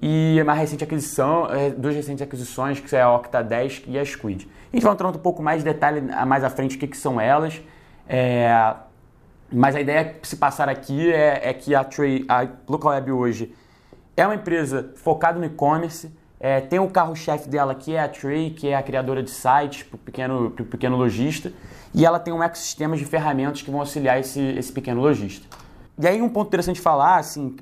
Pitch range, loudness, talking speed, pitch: 130-160 Hz, -22 LUFS, 210 wpm, 145 Hz